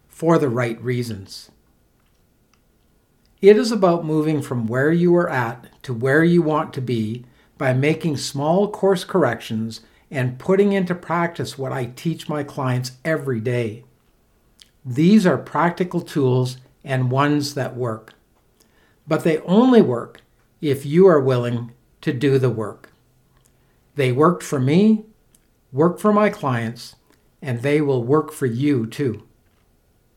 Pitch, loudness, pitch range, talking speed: 140 Hz, -20 LUFS, 125-165 Hz, 140 wpm